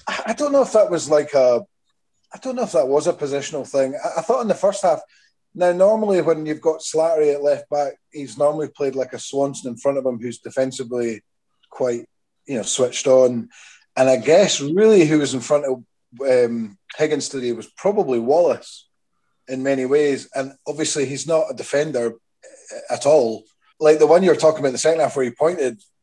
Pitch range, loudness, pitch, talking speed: 130-165 Hz, -19 LUFS, 145 Hz, 205 wpm